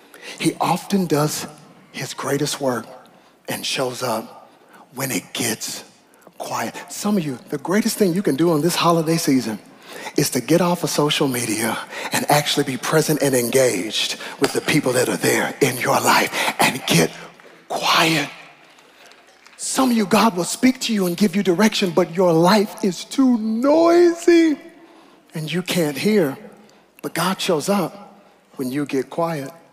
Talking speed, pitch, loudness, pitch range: 165 wpm, 175 Hz, -19 LUFS, 150-215 Hz